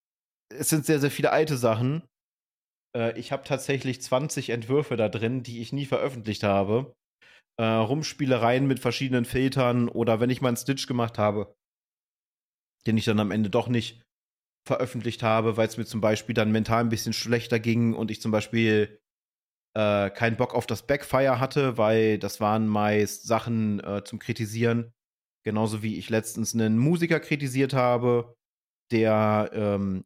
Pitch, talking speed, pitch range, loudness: 115 Hz, 165 wpm, 110-130 Hz, -26 LUFS